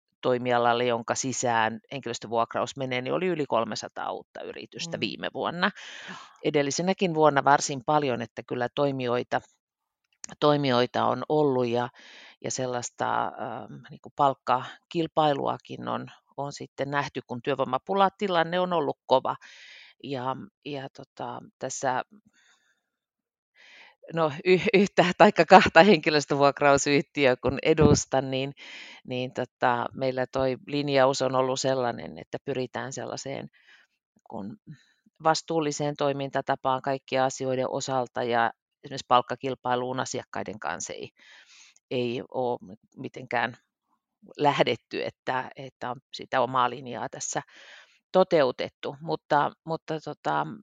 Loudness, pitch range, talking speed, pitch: -26 LUFS, 125-150 Hz, 105 wpm, 135 Hz